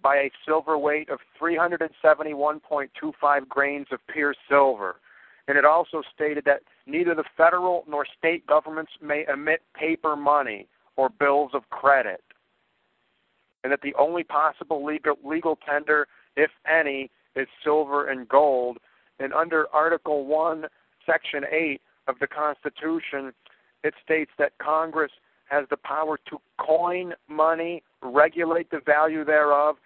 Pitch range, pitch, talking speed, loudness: 145-160 Hz, 150 Hz, 135 wpm, -24 LUFS